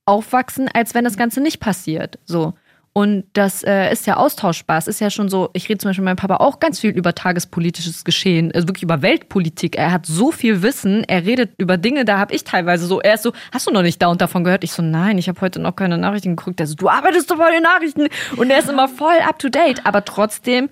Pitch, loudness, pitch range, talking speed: 200 Hz, -17 LUFS, 180-245 Hz, 260 wpm